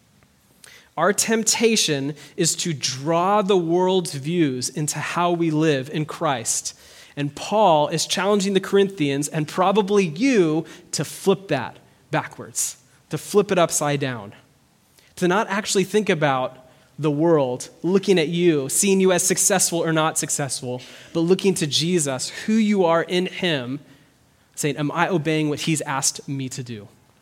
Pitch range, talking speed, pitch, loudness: 140-185 Hz, 150 wpm, 160 Hz, -21 LUFS